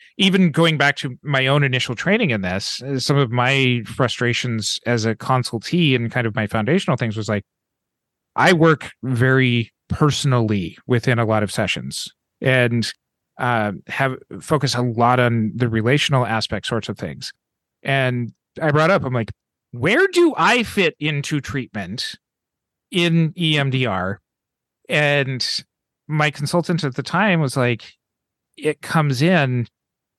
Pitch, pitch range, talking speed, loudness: 130 Hz, 115-150 Hz, 145 wpm, -19 LUFS